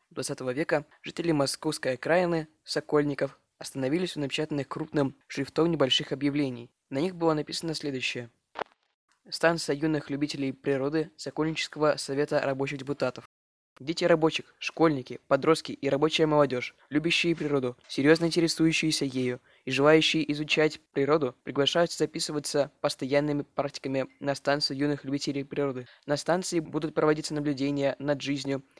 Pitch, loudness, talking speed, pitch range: 145 Hz, -28 LUFS, 120 wpm, 140-160 Hz